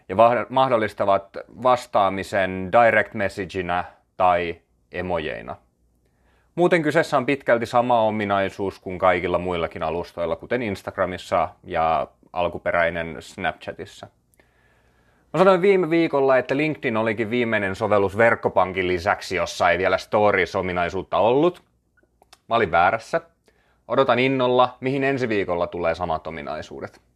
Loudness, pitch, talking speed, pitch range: -21 LUFS, 95 Hz, 105 wpm, 85-125 Hz